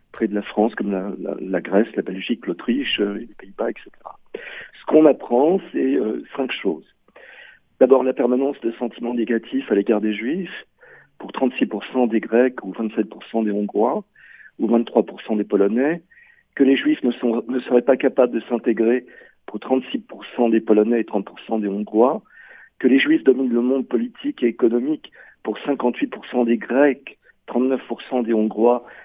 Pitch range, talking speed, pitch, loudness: 115-135 Hz, 165 wpm, 120 Hz, -20 LUFS